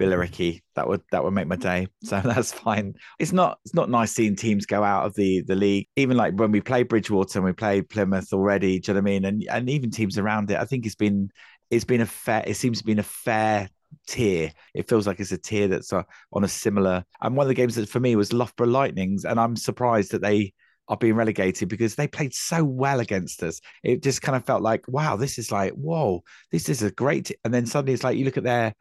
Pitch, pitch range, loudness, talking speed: 110 Hz, 100-125 Hz, -24 LUFS, 260 wpm